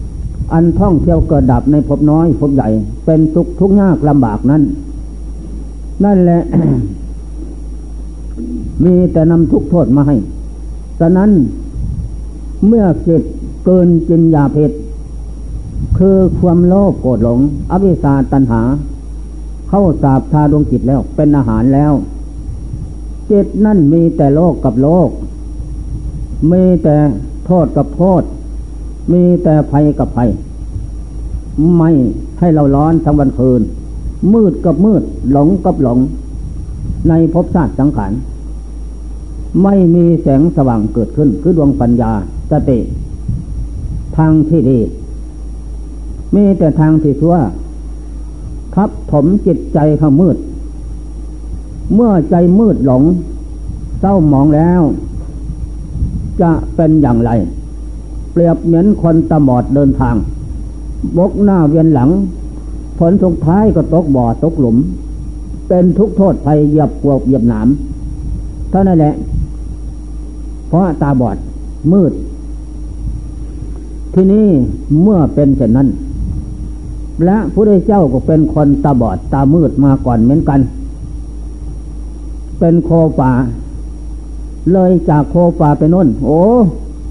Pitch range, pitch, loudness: 120-170 Hz, 150 Hz, -11 LUFS